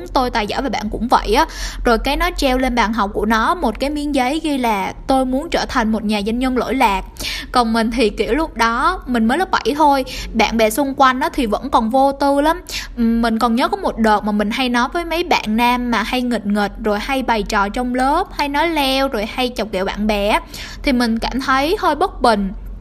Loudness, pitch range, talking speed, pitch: -17 LUFS, 225-285 Hz, 250 wpm, 250 Hz